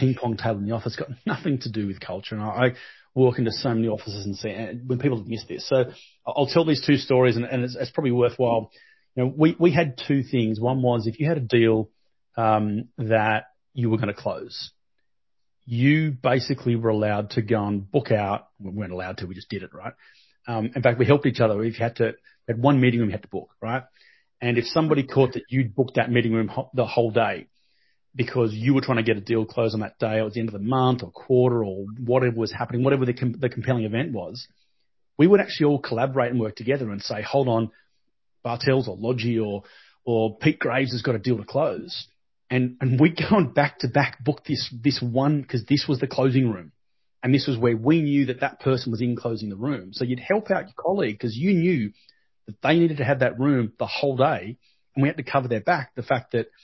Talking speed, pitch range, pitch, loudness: 245 wpm, 115-135 Hz, 125 Hz, -23 LUFS